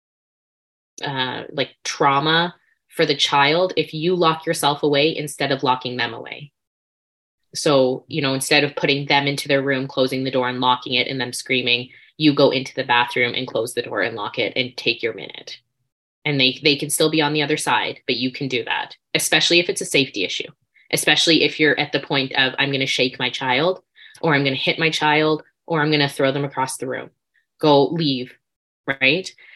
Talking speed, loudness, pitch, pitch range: 210 wpm, -19 LUFS, 140 Hz, 130-155 Hz